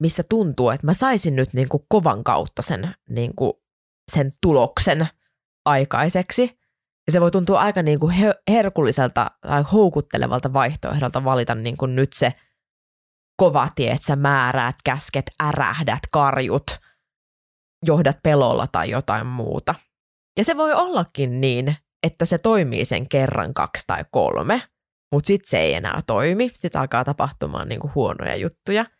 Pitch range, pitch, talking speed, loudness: 130-180 Hz, 145 Hz, 145 wpm, -20 LUFS